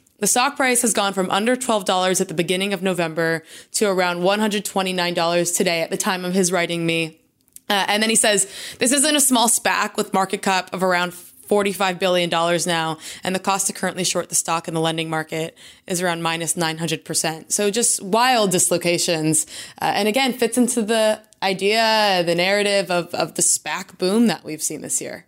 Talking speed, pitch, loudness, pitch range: 195 wpm, 190 Hz, -19 LUFS, 170-210 Hz